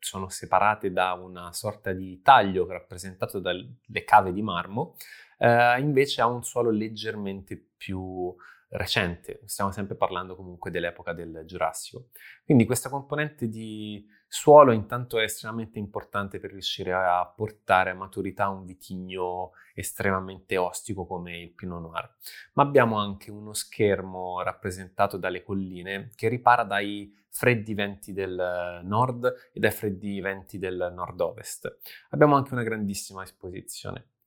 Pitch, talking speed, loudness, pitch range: 100 Hz, 135 wpm, -26 LUFS, 95-115 Hz